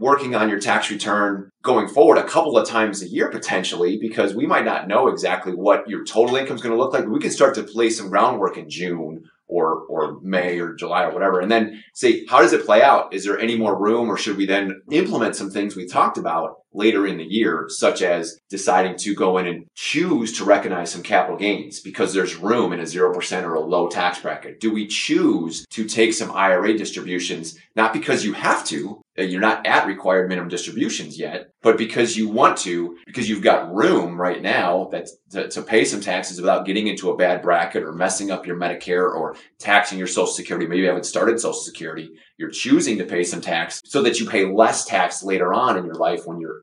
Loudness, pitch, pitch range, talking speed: -20 LUFS, 100 Hz, 90-110 Hz, 225 wpm